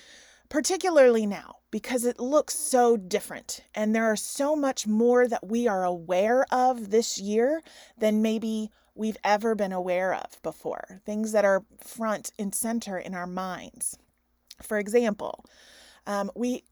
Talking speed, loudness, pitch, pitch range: 145 wpm, -26 LUFS, 225 Hz, 205-250 Hz